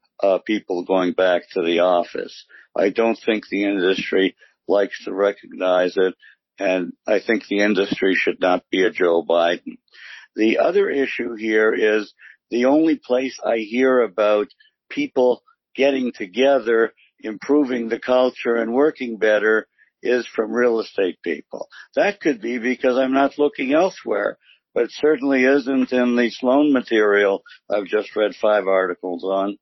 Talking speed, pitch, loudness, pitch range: 150 wpm, 115 Hz, -20 LUFS, 105-135 Hz